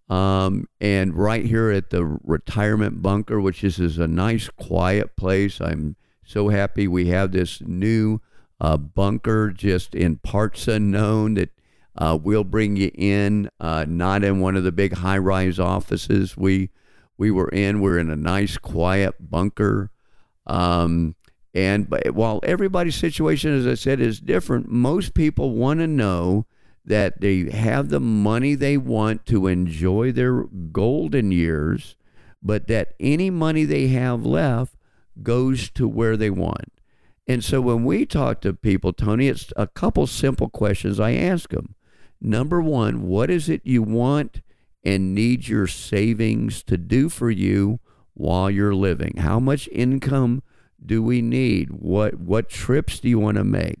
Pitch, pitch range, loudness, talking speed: 105 Hz, 95-120 Hz, -21 LUFS, 160 wpm